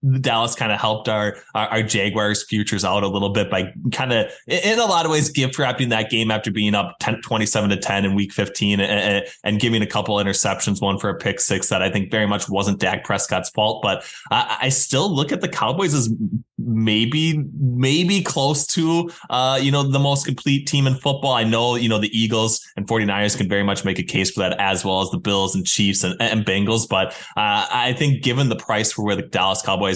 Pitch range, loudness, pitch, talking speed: 100-130 Hz, -19 LUFS, 110 Hz, 230 wpm